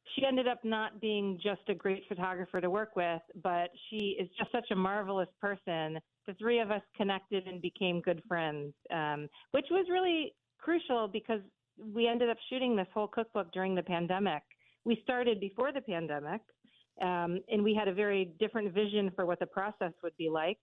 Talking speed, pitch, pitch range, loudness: 190 wpm, 200 Hz, 180-220 Hz, -34 LUFS